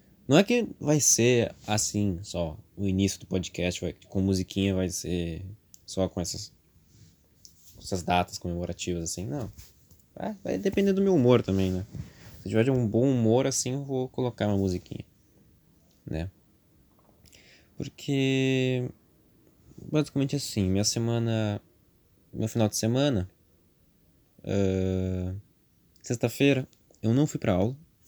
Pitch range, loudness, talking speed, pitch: 90-125 Hz, -27 LUFS, 130 wpm, 100 Hz